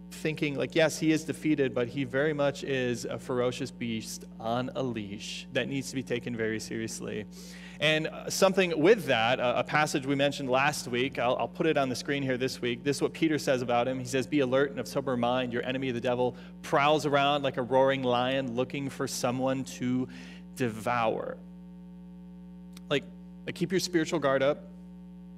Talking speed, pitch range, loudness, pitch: 190 wpm, 125-165 Hz, -29 LUFS, 140 Hz